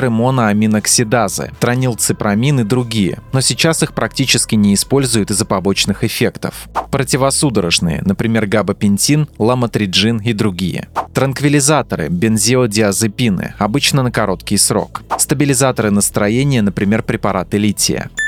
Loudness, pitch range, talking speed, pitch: -14 LUFS, 105-130 Hz, 100 wpm, 115 Hz